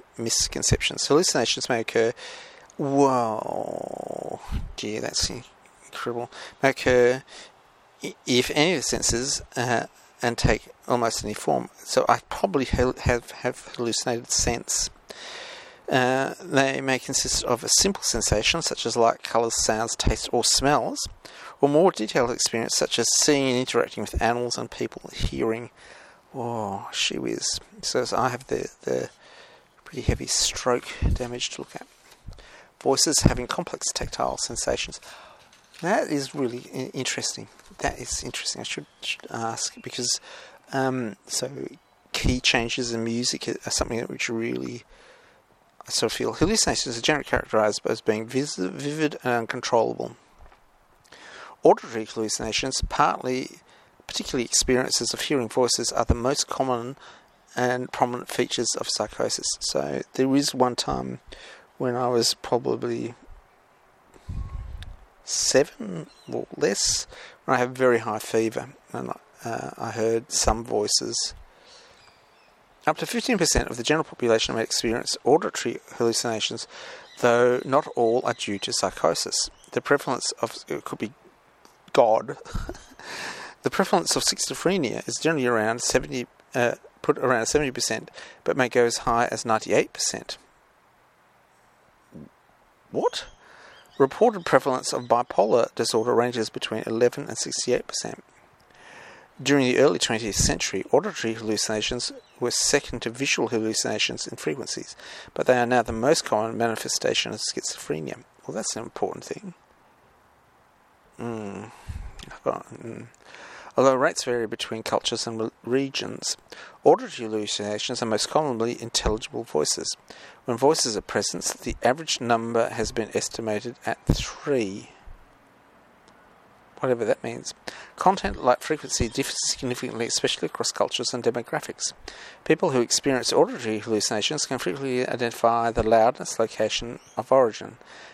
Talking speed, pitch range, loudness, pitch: 130 wpm, 115-130 Hz, -24 LUFS, 120 Hz